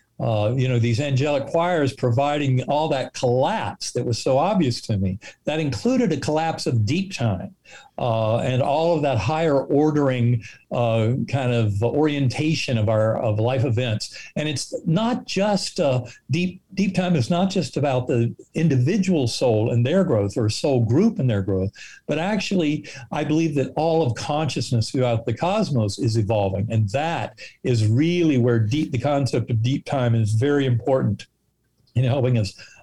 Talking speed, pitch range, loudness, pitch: 170 wpm, 115-155 Hz, -22 LUFS, 130 Hz